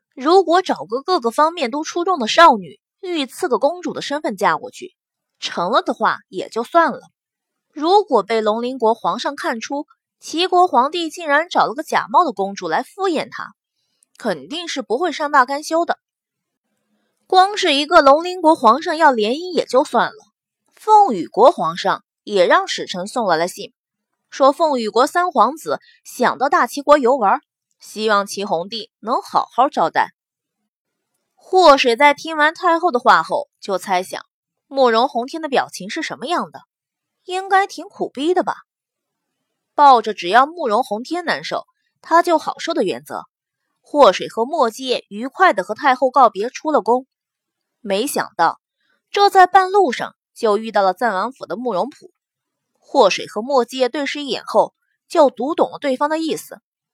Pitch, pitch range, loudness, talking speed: 295 Hz, 245-355 Hz, -17 LUFS, 240 characters per minute